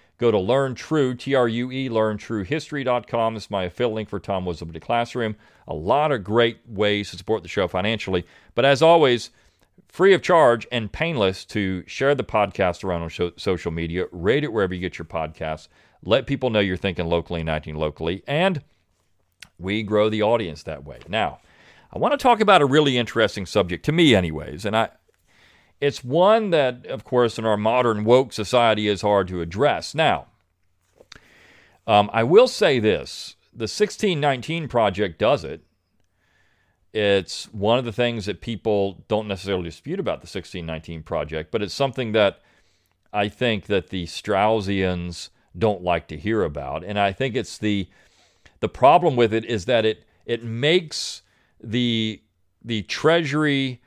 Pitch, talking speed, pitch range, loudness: 105 Hz, 165 wpm, 90-125 Hz, -22 LUFS